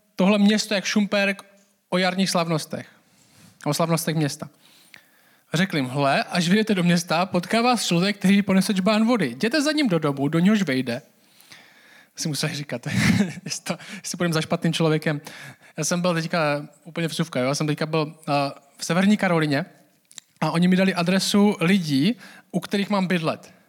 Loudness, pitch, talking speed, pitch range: -22 LUFS, 175 Hz, 160 wpm, 155-200 Hz